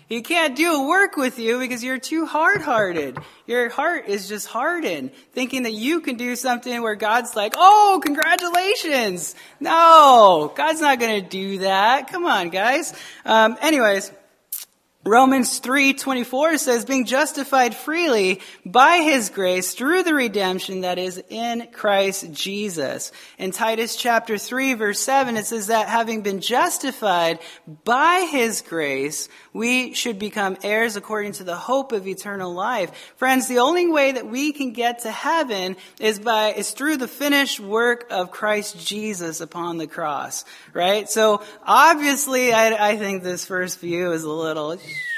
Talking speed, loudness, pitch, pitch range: 155 wpm, -19 LUFS, 230 Hz, 200-270 Hz